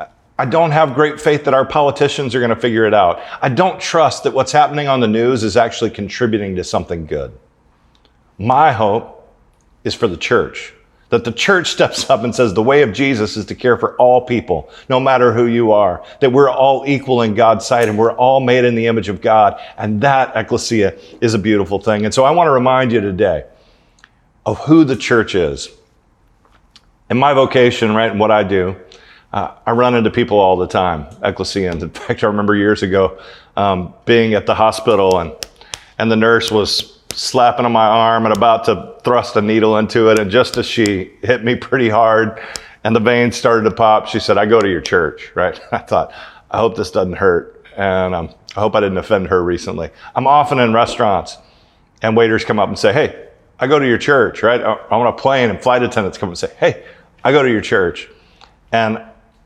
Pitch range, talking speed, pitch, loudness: 105-125 Hz, 210 wpm, 115 Hz, -14 LUFS